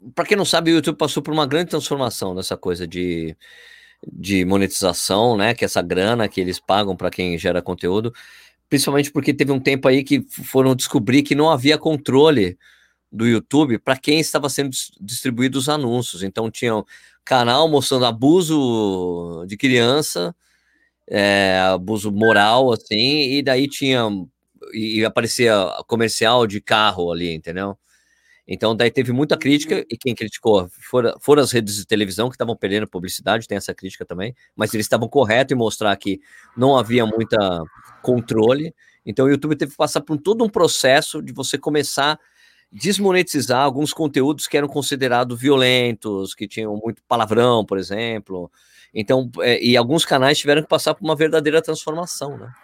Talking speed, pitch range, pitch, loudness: 165 wpm, 105-145 Hz, 125 Hz, -18 LUFS